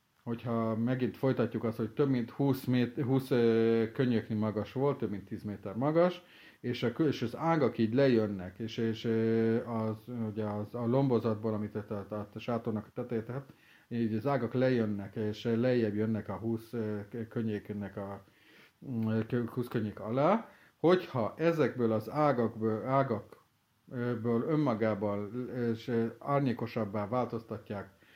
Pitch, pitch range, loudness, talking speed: 115 Hz, 110-125 Hz, -32 LUFS, 130 wpm